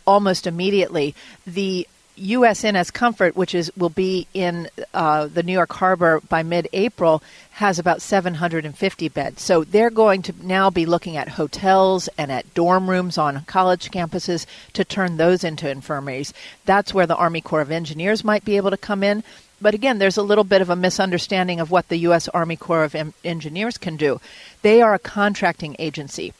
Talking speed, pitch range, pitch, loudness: 185 wpm, 165-195 Hz, 180 Hz, -20 LUFS